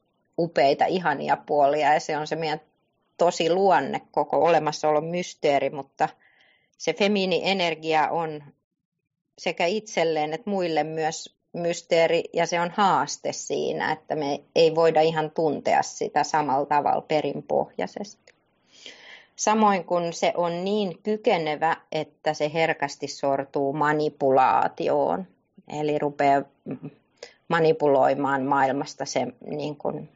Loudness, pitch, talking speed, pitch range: -24 LUFS, 155 Hz, 115 wpm, 145-170 Hz